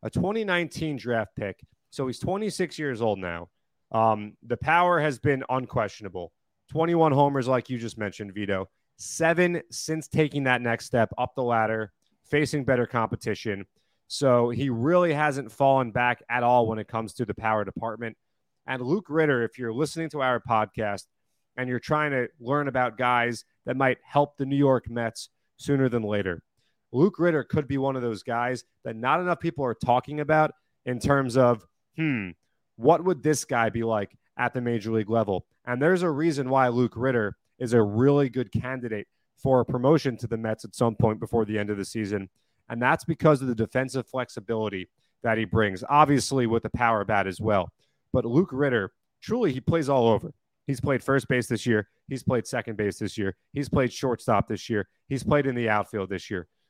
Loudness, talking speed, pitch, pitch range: -26 LUFS, 195 wpm, 125 Hz, 110-140 Hz